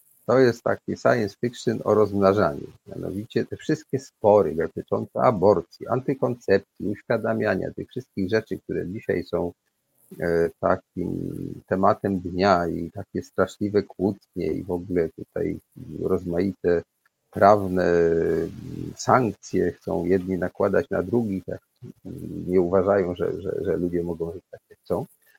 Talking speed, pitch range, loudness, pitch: 120 wpm, 85-105 Hz, -24 LUFS, 95 Hz